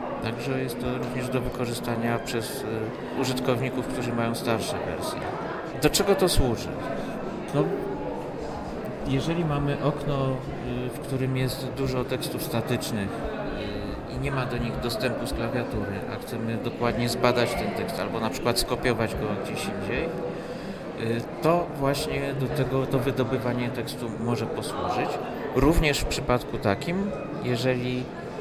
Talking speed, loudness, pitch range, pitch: 130 wpm, -28 LUFS, 120-140 Hz, 130 Hz